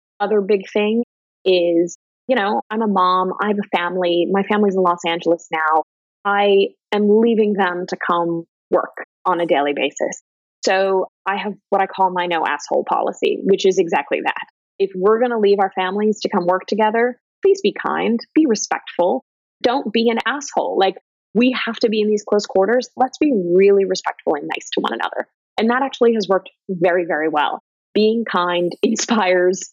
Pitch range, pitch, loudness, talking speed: 185-230 Hz, 200 Hz, -18 LUFS, 190 wpm